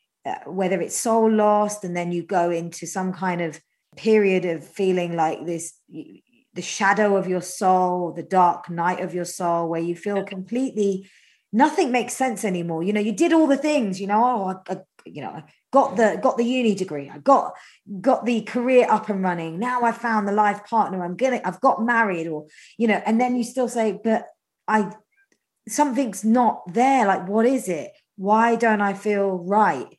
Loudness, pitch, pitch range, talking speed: -22 LUFS, 205 Hz, 180-235 Hz, 200 wpm